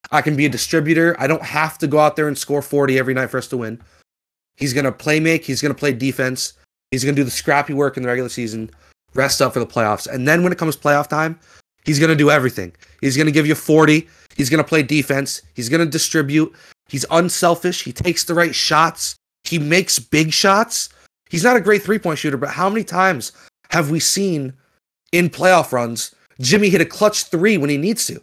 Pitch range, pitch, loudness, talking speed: 130-165 Hz, 150 Hz, -17 LUFS, 235 wpm